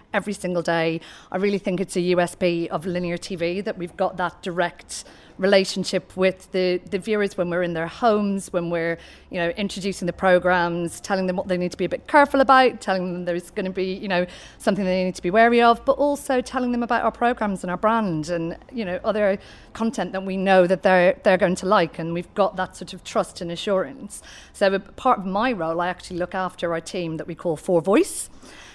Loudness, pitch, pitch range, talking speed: -22 LUFS, 185 Hz, 175-205 Hz, 230 wpm